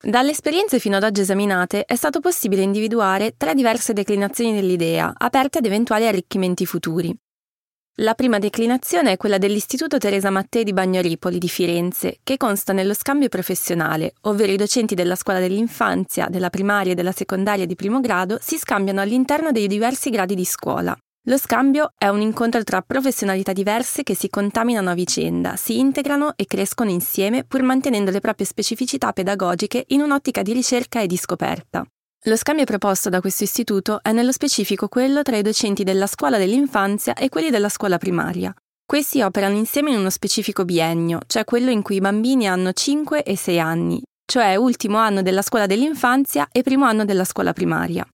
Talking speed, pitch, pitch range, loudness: 175 wpm, 210 Hz, 190-250 Hz, -19 LUFS